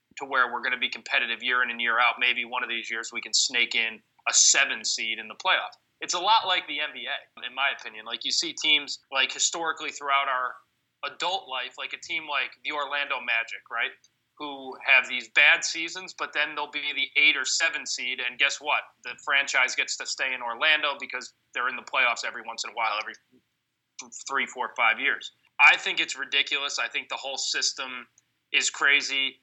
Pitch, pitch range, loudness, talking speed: 140 Hz, 125-155 Hz, -24 LUFS, 210 wpm